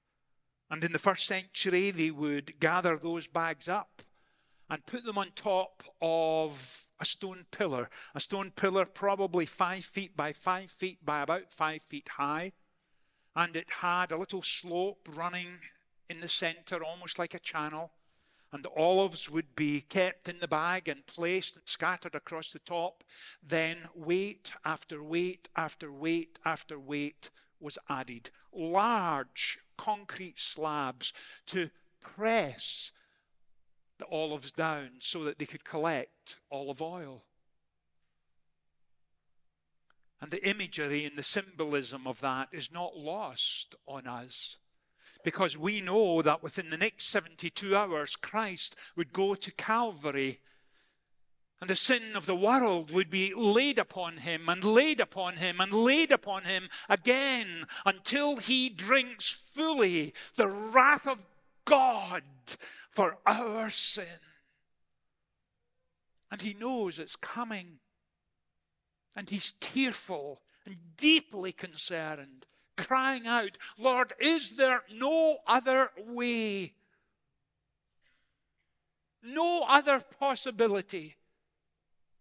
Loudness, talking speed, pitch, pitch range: -31 LUFS, 125 wpm, 180 Hz, 155-205 Hz